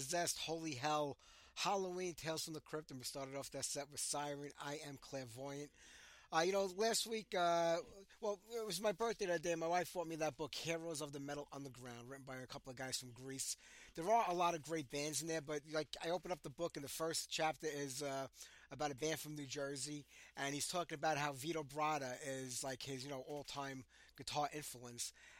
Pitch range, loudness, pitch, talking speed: 140-165 Hz, -43 LUFS, 150 Hz, 225 wpm